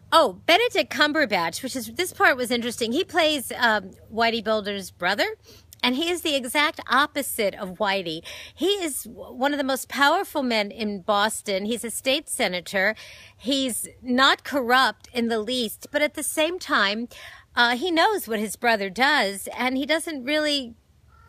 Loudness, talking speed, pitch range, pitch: -23 LUFS, 165 wpm, 220-300 Hz, 255 Hz